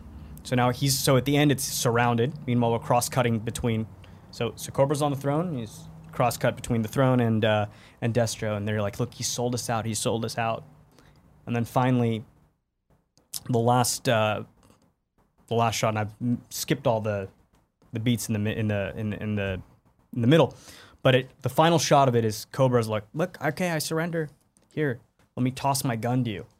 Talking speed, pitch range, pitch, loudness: 200 wpm, 110-130 Hz, 120 Hz, -26 LUFS